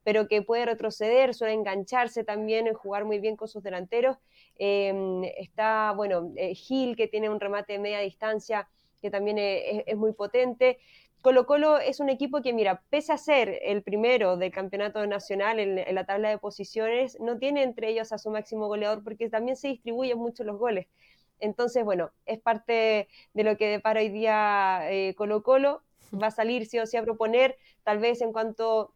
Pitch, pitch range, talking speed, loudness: 220 Hz, 205-240 Hz, 195 wpm, -27 LUFS